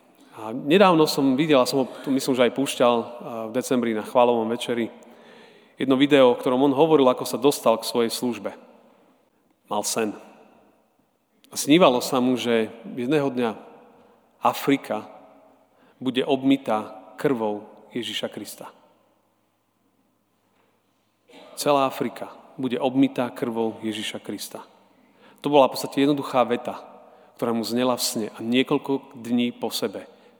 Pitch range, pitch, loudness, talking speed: 115-135 Hz, 125 Hz, -23 LUFS, 130 wpm